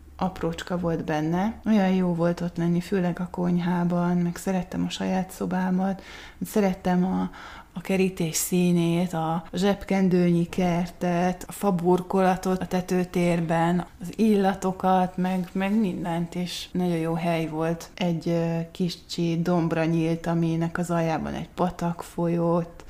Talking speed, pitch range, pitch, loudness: 125 wpm, 170-185 Hz, 175 Hz, -25 LUFS